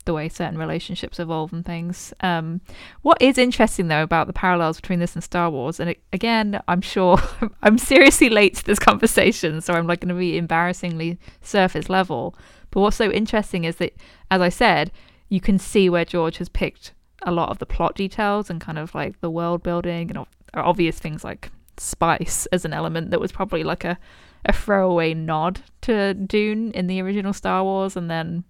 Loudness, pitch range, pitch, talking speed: -21 LUFS, 170-200 Hz, 180 Hz, 200 wpm